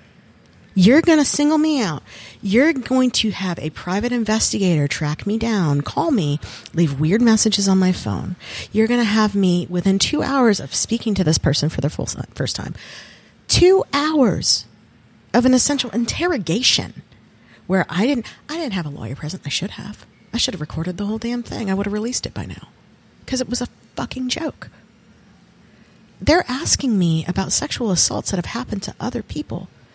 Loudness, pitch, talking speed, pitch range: -19 LUFS, 205 Hz, 185 wpm, 165-245 Hz